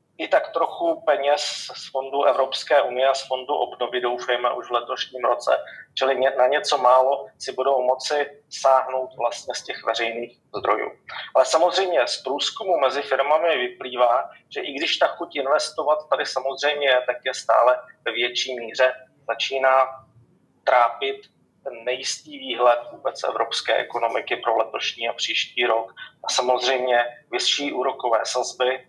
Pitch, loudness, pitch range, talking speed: 130 Hz, -22 LUFS, 125-145 Hz, 145 wpm